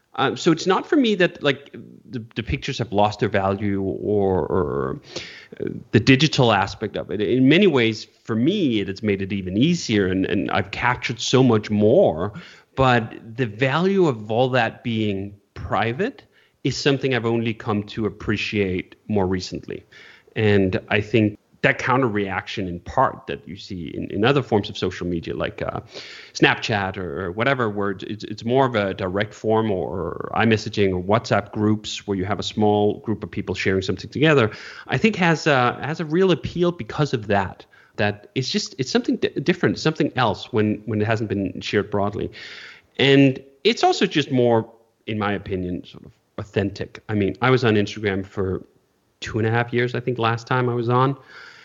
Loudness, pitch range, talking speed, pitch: -21 LUFS, 100-130 Hz, 195 wpm, 110 Hz